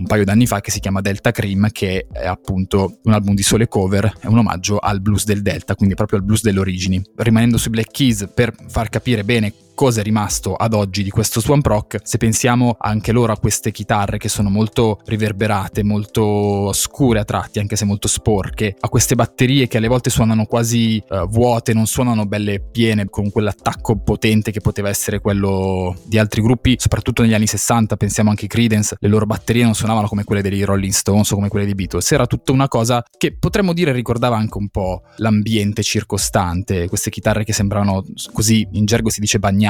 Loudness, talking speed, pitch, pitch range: -17 LUFS, 205 wpm, 105 Hz, 100-115 Hz